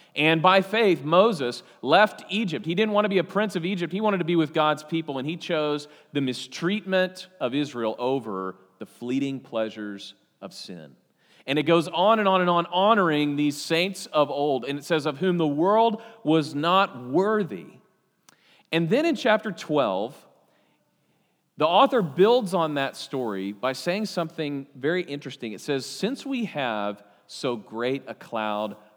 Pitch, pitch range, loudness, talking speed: 160 Hz, 135-190 Hz, -24 LUFS, 170 wpm